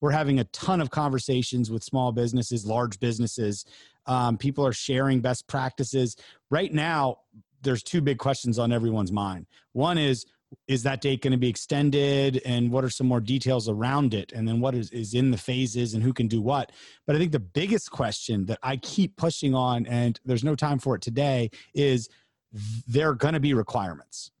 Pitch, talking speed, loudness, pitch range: 130 Hz, 200 wpm, -26 LUFS, 115-140 Hz